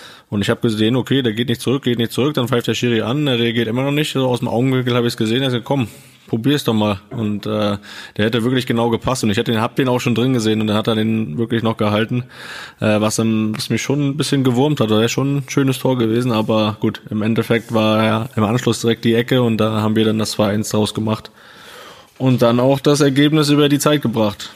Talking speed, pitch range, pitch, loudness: 260 wpm, 110-130 Hz, 115 Hz, -17 LUFS